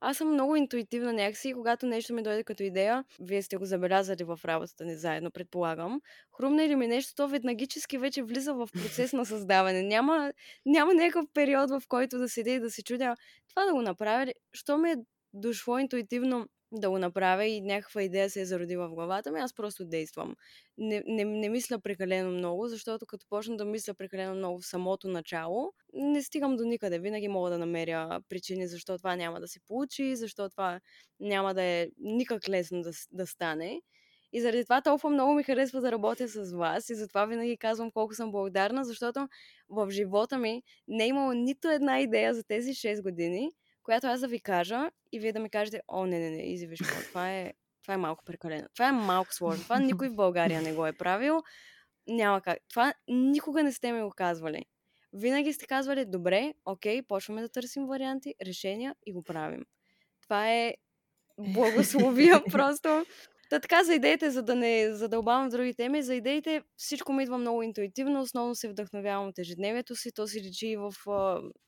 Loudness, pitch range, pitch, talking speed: -31 LUFS, 190-260 Hz, 225 Hz, 195 wpm